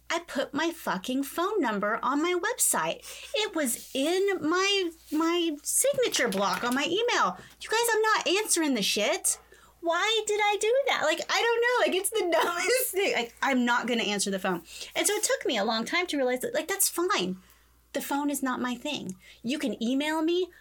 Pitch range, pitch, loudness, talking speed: 255-400 Hz, 325 Hz, -27 LUFS, 205 wpm